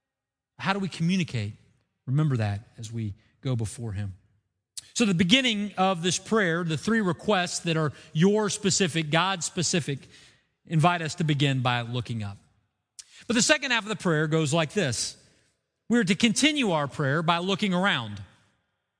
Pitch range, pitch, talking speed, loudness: 120-195 Hz, 160 Hz, 160 wpm, -25 LUFS